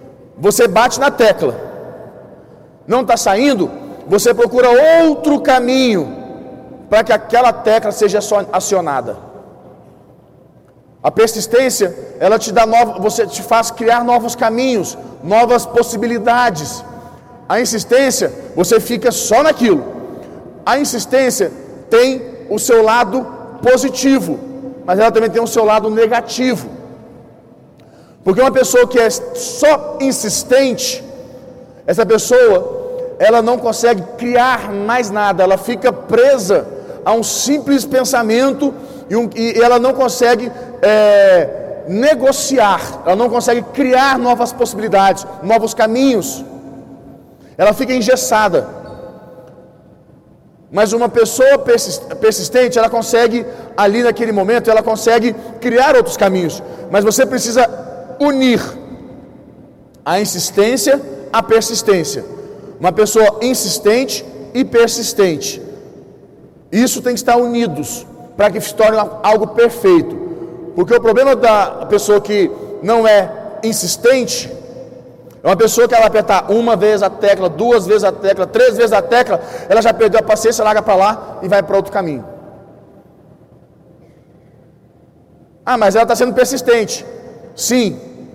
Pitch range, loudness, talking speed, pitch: 215-255 Hz, -13 LUFS, 120 wpm, 235 Hz